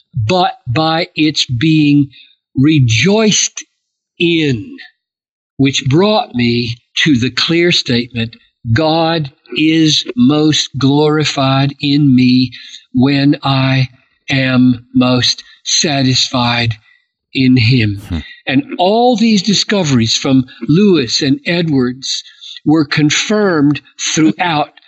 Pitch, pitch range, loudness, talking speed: 140 Hz, 125-160 Hz, -12 LUFS, 90 wpm